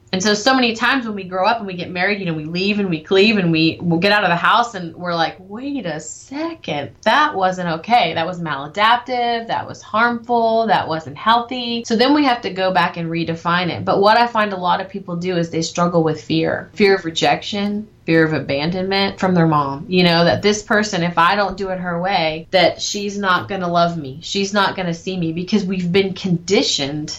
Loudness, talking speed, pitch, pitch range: -17 LUFS, 240 wpm, 185 Hz, 170-210 Hz